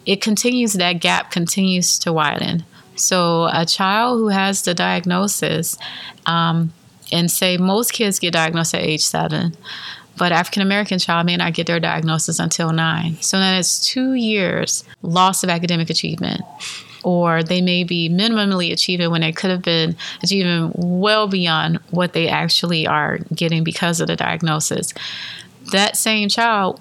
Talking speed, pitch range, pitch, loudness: 155 wpm, 165-190 Hz, 175 Hz, -17 LUFS